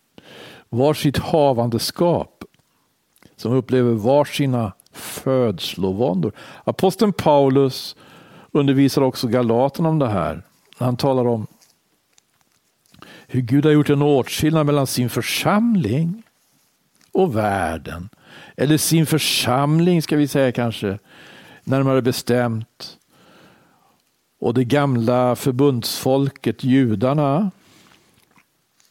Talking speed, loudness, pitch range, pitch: 85 wpm, -19 LUFS, 125-145 Hz, 135 Hz